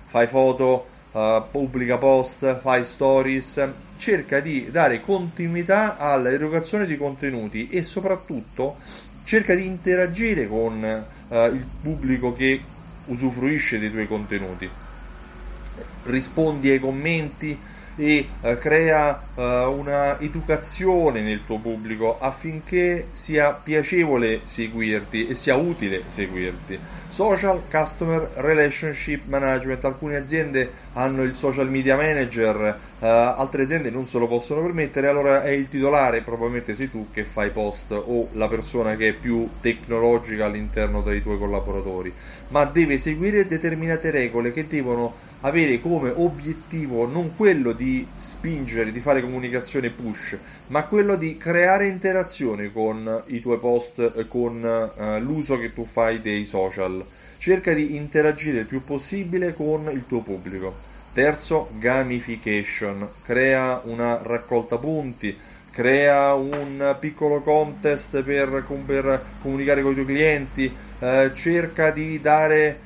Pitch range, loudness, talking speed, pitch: 115-155 Hz, -22 LUFS, 125 wpm, 135 Hz